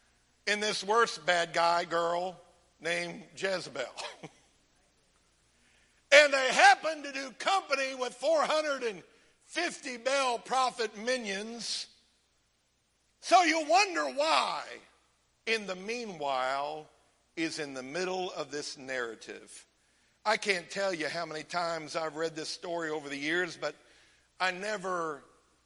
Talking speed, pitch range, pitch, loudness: 115 wpm, 165-255 Hz, 185 Hz, -30 LUFS